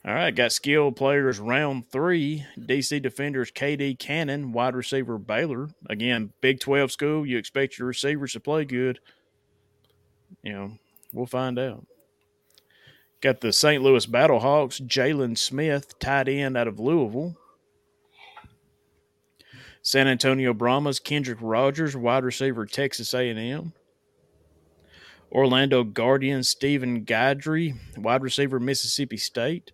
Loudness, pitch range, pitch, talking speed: -24 LUFS, 120-140 Hz, 130 Hz, 120 wpm